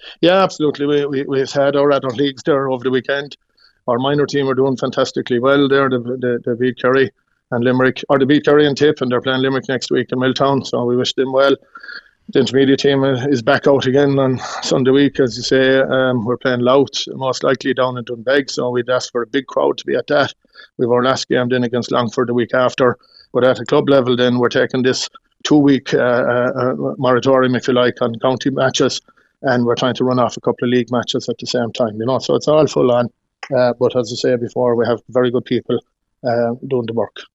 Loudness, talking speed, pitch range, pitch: -16 LUFS, 235 wpm, 125-135 Hz, 130 Hz